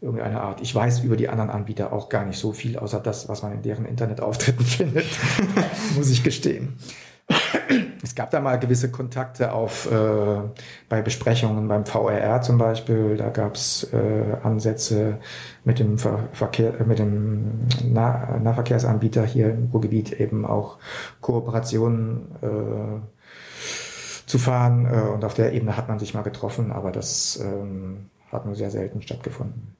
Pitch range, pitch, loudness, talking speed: 105-120 Hz, 115 Hz, -23 LUFS, 155 wpm